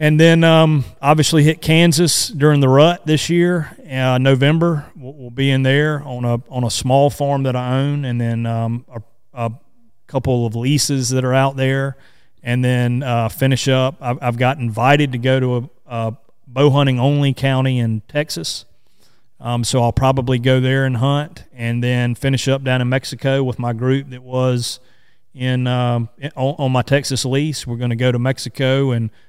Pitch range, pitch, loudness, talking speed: 120-140 Hz, 130 Hz, -17 LUFS, 190 wpm